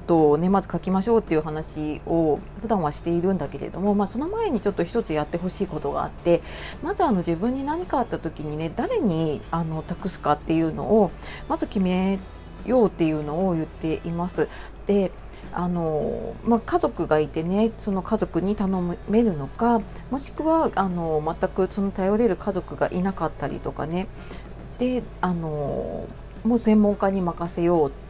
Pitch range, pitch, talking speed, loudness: 160-210 Hz, 185 Hz, 345 characters per minute, -24 LUFS